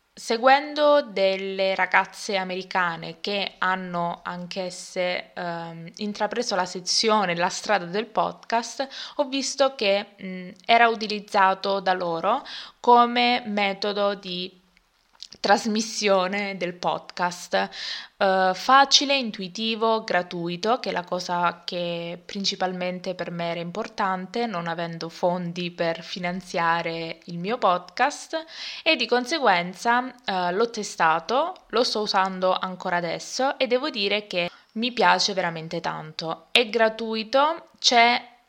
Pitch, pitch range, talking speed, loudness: 195 Hz, 180-230 Hz, 115 wpm, -24 LUFS